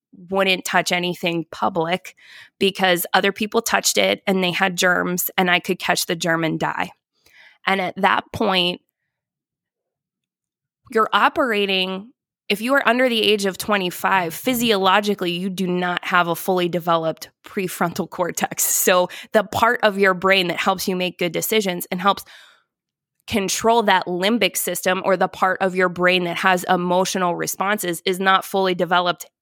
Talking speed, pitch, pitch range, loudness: 155 wpm, 190 Hz, 180-200 Hz, -19 LUFS